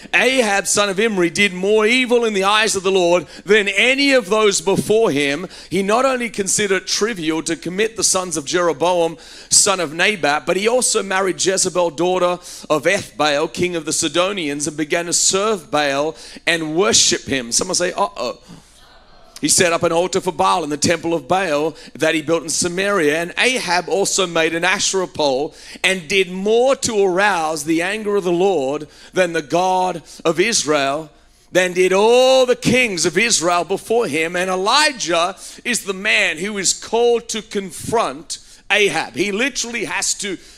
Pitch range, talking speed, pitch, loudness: 165-210 Hz, 180 wpm, 185 Hz, -17 LUFS